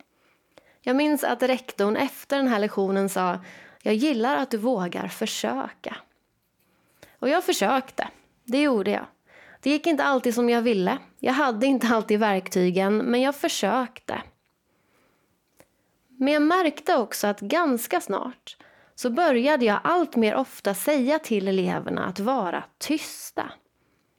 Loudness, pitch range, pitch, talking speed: -24 LUFS, 210-285 Hz, 250 Hz, 135 wpm